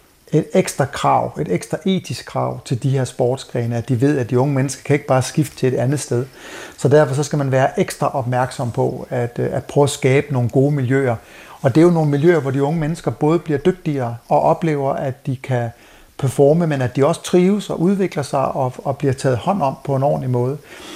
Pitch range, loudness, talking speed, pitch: 130-150 Hz, -18 LUFS, 225 wpm, 140 Hz